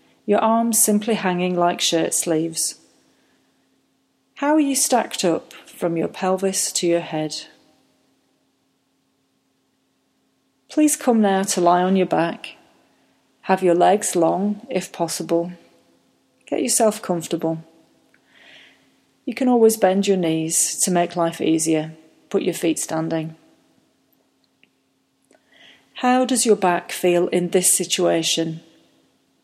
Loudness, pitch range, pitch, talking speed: -19 LUFS, 165-210 Hz, 180 Hz, 115 wpm